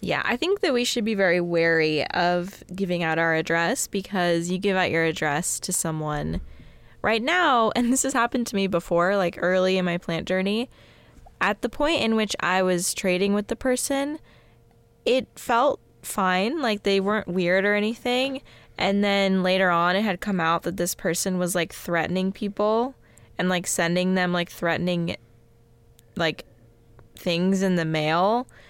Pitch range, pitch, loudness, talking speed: 170-210 Hz, 185 Hz, -23 LUFS, 175 wpm